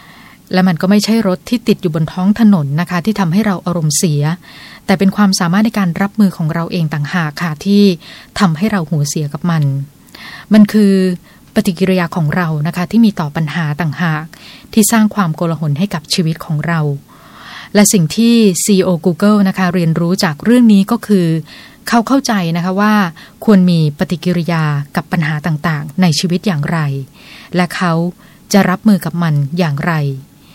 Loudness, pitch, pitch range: -13 LUFS, 180 Hz, 165-205 Hz